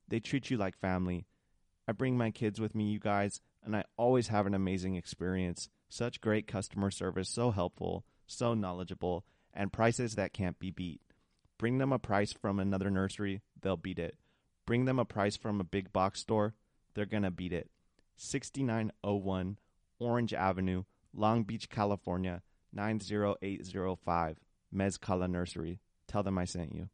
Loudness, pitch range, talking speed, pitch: -35 LUFS, 90-110 Hz, 160 wpm, 100 Hz